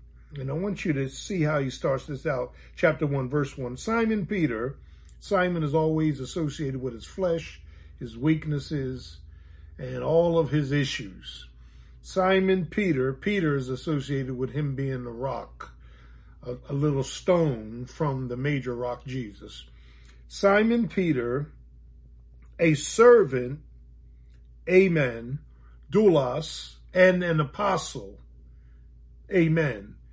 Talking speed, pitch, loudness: 120 wpm, 135 Hz, -26 LUFS